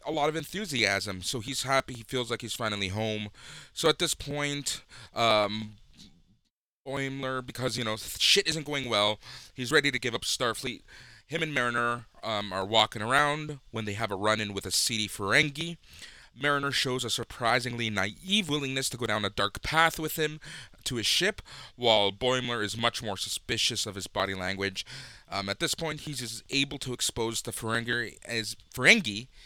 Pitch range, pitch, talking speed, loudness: 105-140 Hz, 120 Hz, 180 wpm, -28 LUFS